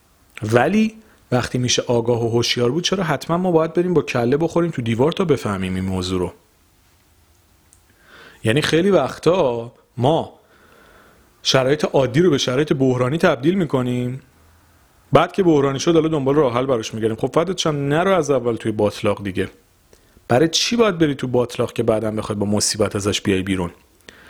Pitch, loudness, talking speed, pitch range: 120 Hz, -19 LUFS, 165 wpm, 105-155 Hz